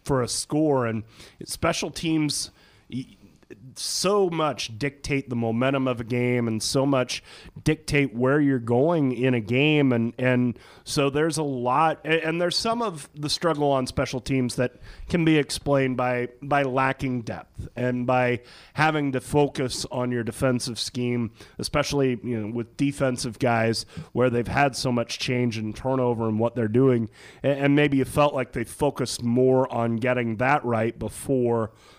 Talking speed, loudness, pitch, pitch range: 165 wpm, -24 LUFS, 130 Hz, 120-145 Hz